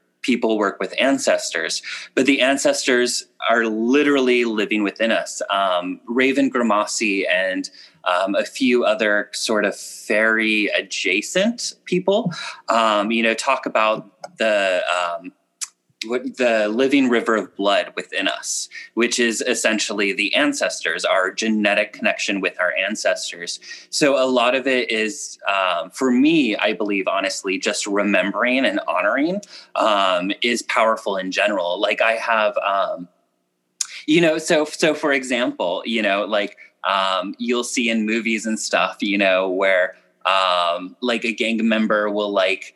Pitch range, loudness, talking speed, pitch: 105-145 Hz, -19 LUFS, 140 wpm, 115 Hz